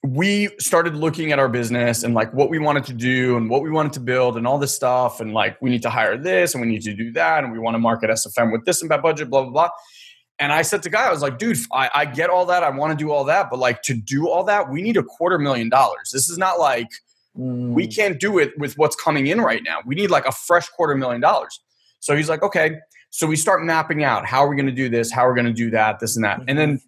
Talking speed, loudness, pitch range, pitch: 295 wpm, -19 LUFS, 120-160 Hz, 140 Hz